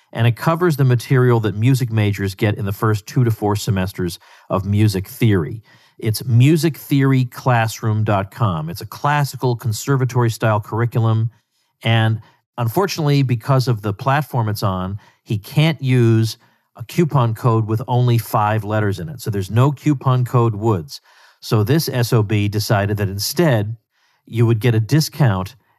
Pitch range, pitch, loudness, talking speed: 110-130 Hz, 115 Hz, -18 LUFS, 150 wpm